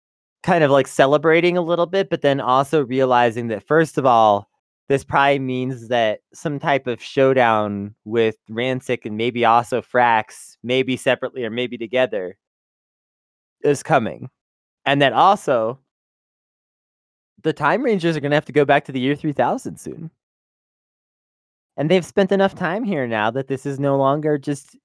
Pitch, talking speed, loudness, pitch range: 135 Hz, 160 wpm, -19 LUFS, 120-150 Hz